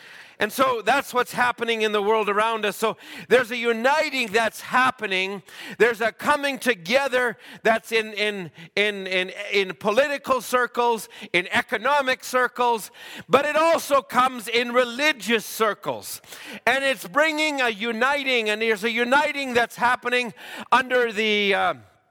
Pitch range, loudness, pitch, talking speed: 215-255 Hz, -22 LUFS, 240 Hz, 140 wpm